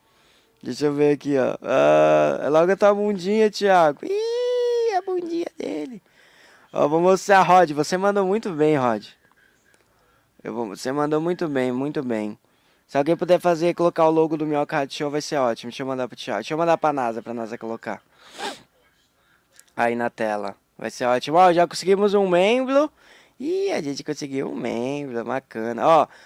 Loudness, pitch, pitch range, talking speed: -21 LUFS, 150 Hz, 125-190 Hz, 180 wpm